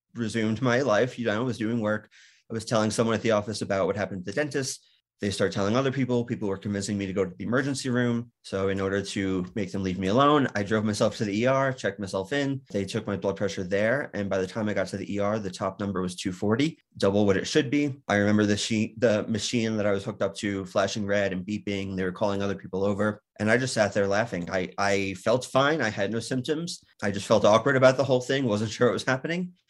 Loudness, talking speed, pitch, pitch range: -26 LUFS, 260 wpm, 105 Hz, 100-125 Hz